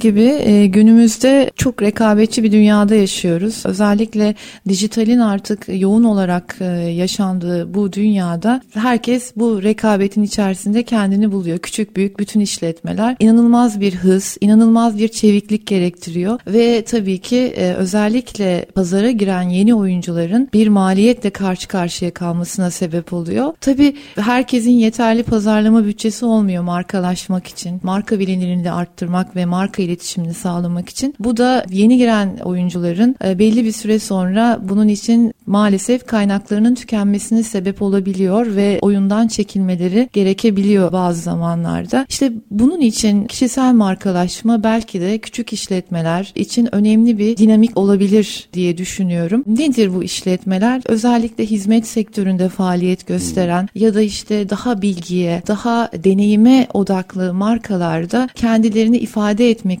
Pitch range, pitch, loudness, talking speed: 185-225 Hz, 210 Hz, -15 LUFS, 125 wpm